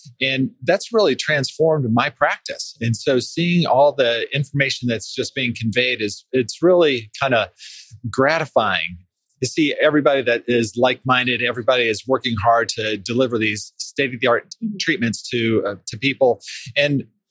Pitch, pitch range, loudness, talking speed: 125 Hz, 115-145 Hz, -19 LUFS, 150 wpm